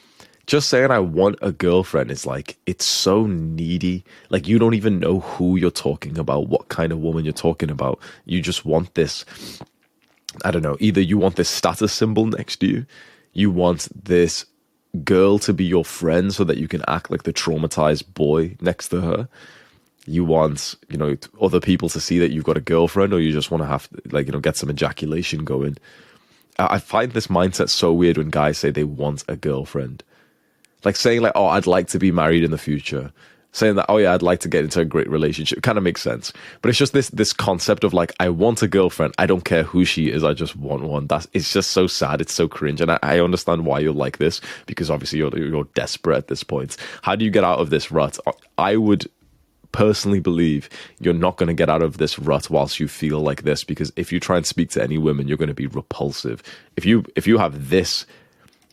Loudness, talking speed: -20 LUFS, 225 wpm